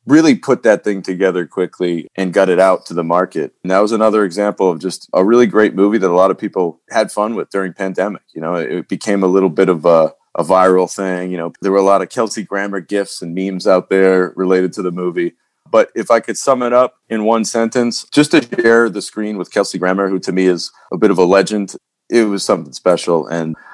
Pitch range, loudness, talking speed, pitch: 90-110 Hz, -15 LUFS, 245 wpm, 95 Hz